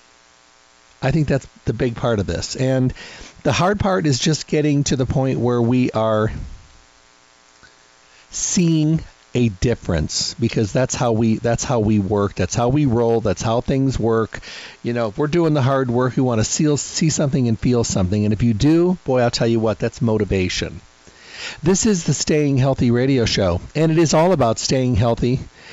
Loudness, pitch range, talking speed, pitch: -19 LUFS, 105-140 Hz, 185 wpm, 120 Hz